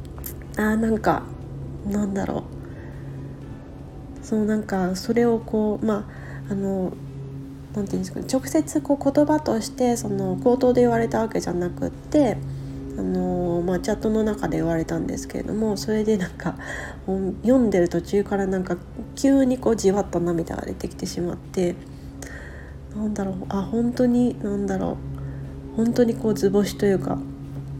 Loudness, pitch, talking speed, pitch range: -23 LUFS, 195 Hz, 305 characters per minute, 135-220 Hz